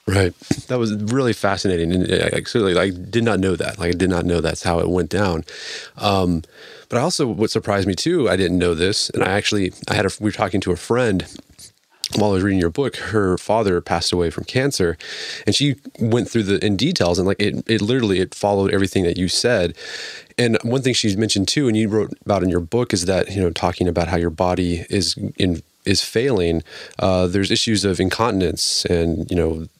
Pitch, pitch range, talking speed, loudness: 95 Hz, 90-110 Hz, 225 wpm, -19 LUFS